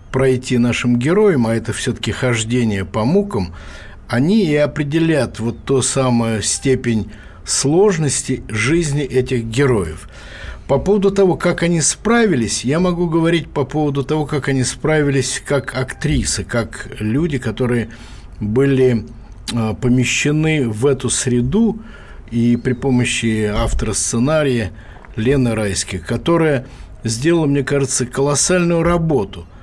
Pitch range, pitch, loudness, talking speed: 115-145 Hz, 130 Hz, -17 LUFS, 115 wpm